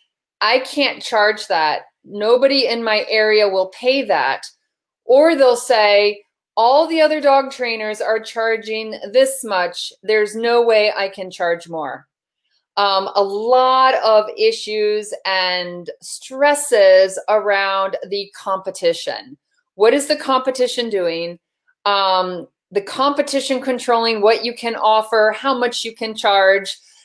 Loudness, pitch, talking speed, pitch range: -16 LUFS, 225 Hz, 130 wpm, 200-270 Hz